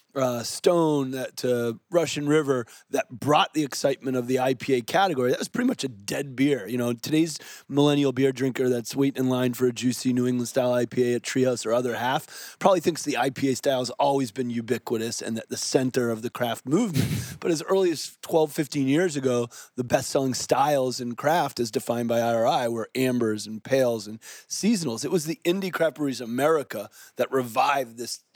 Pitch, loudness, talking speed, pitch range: 130 Hz, -25 LUFS, 200 wpm, 120-145 Hz